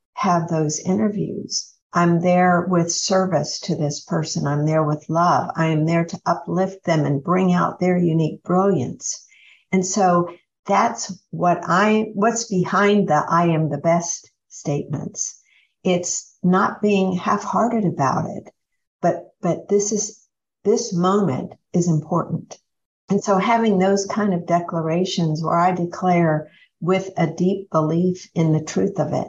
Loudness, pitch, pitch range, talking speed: -20 LUFS, 180 Hz, 165-195 Hz, 150 wpm